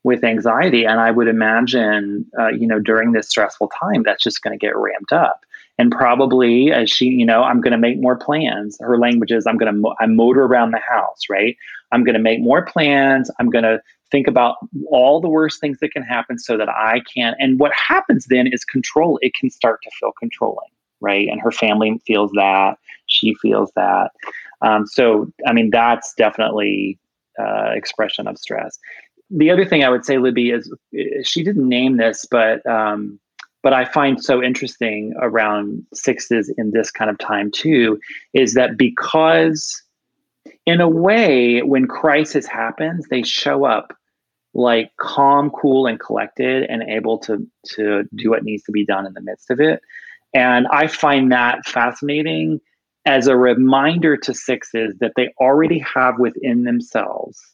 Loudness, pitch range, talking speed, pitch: -16 LUFS, 110-140 Hz, 180 wpm, 120 Hz